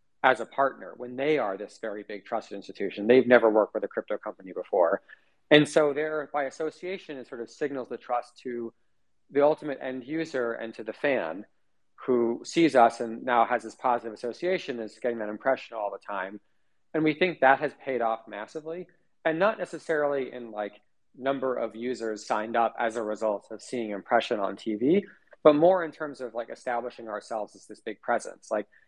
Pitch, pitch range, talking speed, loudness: 125 Hz, 115-150 Hz, 195 wpm, -28 LUFS